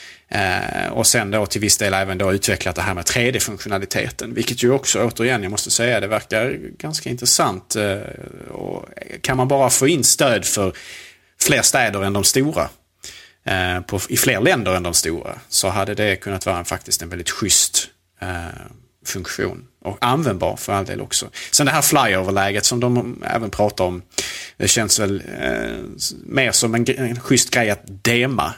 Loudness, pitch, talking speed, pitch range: -18 LUFS, 105 Hz, 185 wpm, 95-120 Hz